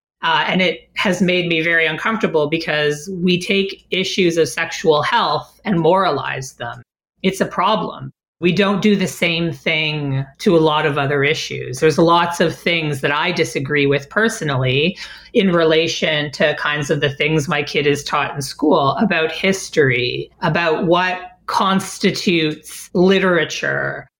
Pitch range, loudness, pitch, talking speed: 150-185 Hz, -17 LUFS, 165 Hz, 150 wpm